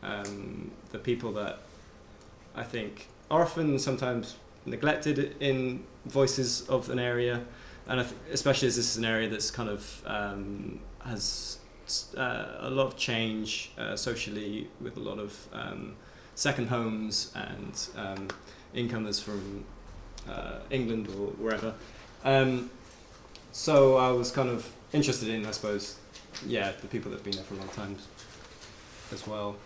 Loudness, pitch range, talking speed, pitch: -31 LUFS, 105-125 Hz, 150 wpm, 110 Hz